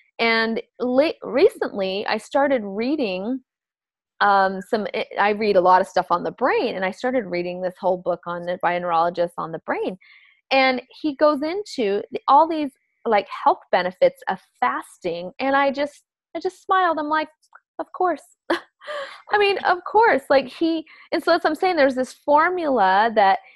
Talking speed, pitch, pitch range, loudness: 175 wpm, 265 Hz, 190-310 Hz, -21 LUFS